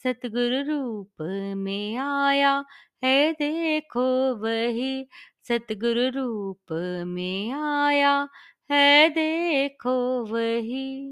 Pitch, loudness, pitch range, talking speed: 255 Hz, -24 LUFS, 230-280 Hz, 75 wpm